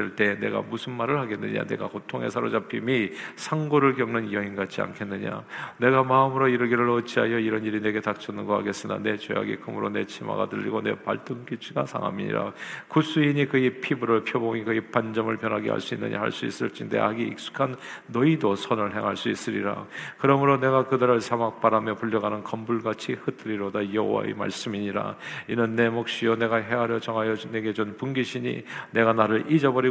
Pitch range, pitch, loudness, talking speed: 105-125 Hz, 115 Hz, -26 LUFS, 405 characters per minute